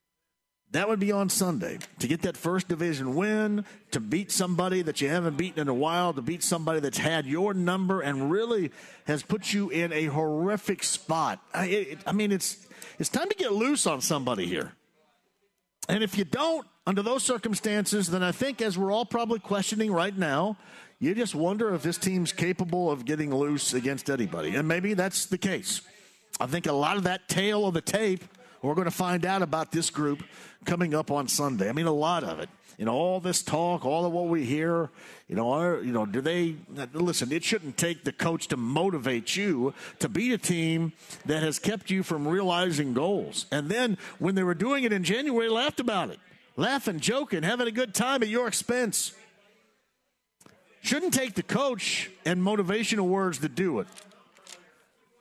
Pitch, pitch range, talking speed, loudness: 185 Hz, 165-210 Hz, 195 wpm, -28 LUFS